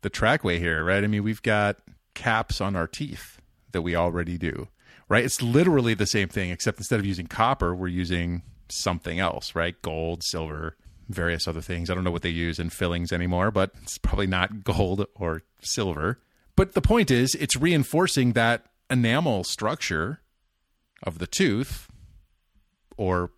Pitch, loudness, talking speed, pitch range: 95 Hz, -25 LUFS, 170 wpm, 85-110 Hz